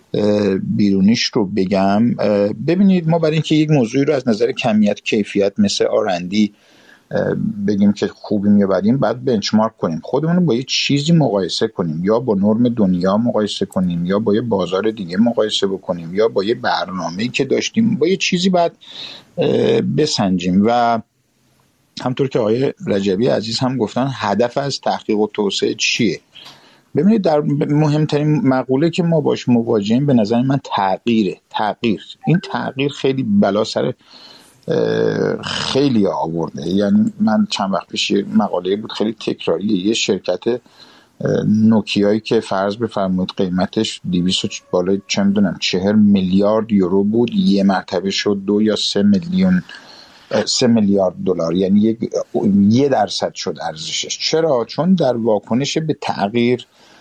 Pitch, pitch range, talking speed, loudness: 120 Hz, 100-165 Hz, 140 wpm, -17 LUFS